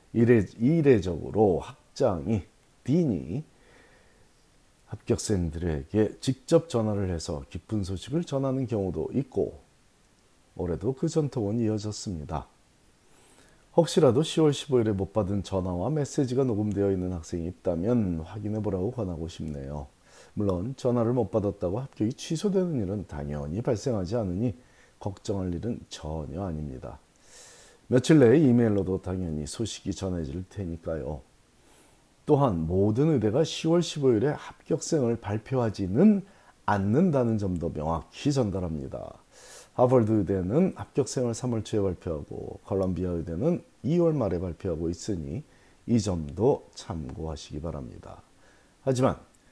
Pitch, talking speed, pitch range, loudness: 105 Hz, 285 characters per minute, 90-125 Hz, -27 LUFS